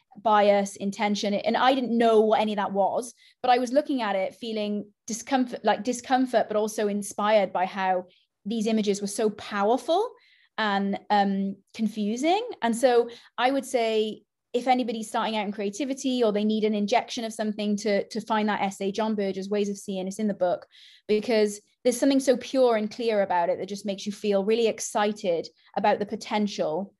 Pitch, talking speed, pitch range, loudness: 215 Hz, 185 wpm, 205-240 Hz, -26 LUFS